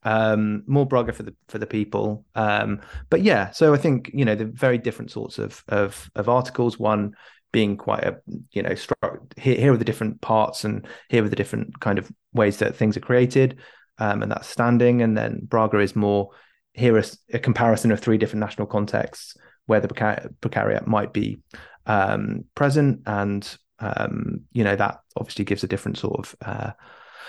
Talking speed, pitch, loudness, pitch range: 190 wpm, 110 Hz, -23 LUFS, 105-120 Hz